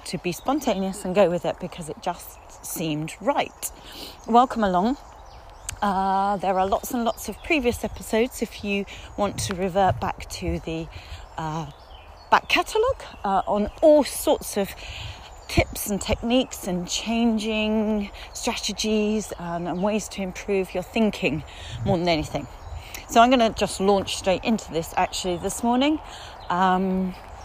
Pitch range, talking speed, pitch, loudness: 180-225 Hz, 150 wpm, 200 Hz, -24 LUFS